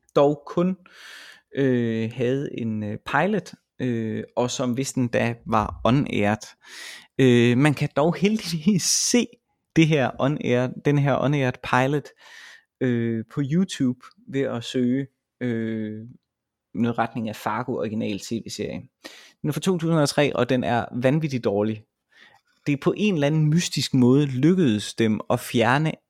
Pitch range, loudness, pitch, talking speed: 120-150 Hz, -23 LUFS, 130 Hz, 140 wpm